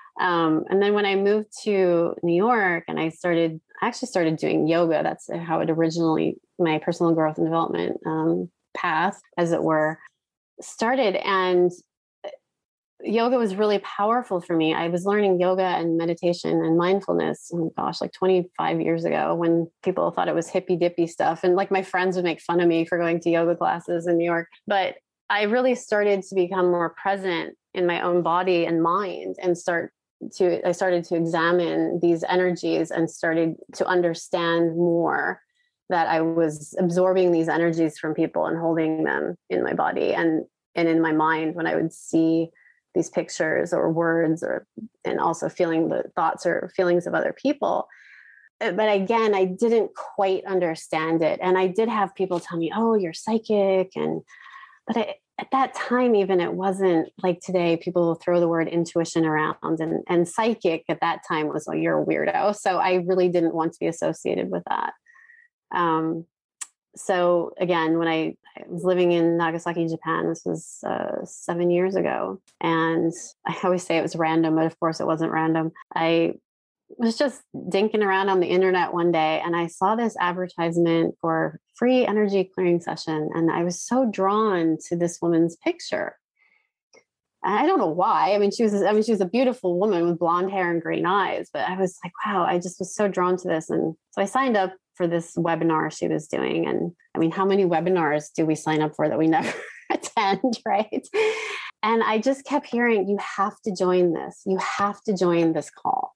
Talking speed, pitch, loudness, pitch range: 190 wpm, 175 Hz, -23 LUFS, 165-195 Hz